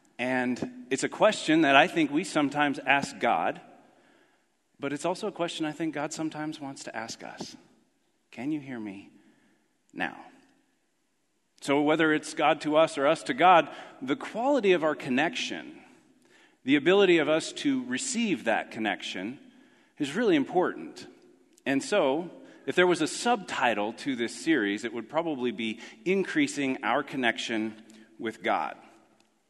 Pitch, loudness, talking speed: 160 Hz, -27 LUFS, 150 wpm